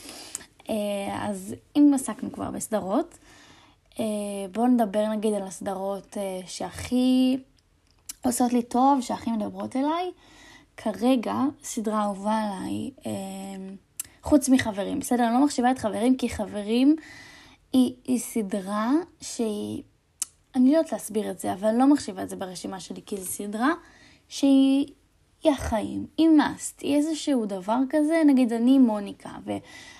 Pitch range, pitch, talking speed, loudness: 210-280 Hz, 245 Hz, 130 wpm, -25 LUFS